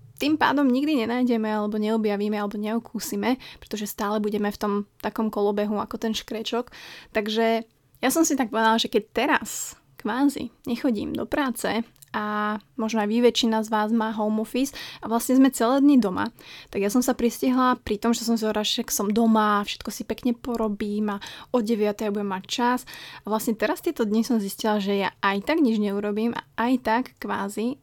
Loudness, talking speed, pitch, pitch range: -24 LUFS, 190 wpm, 225 Hz, 210-245 Hz